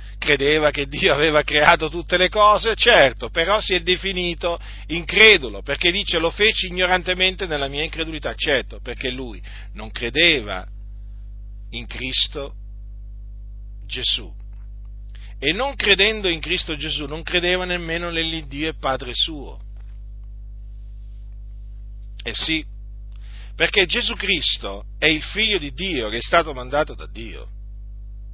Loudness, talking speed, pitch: -18 LUFS, 125 wpm, 140 Hz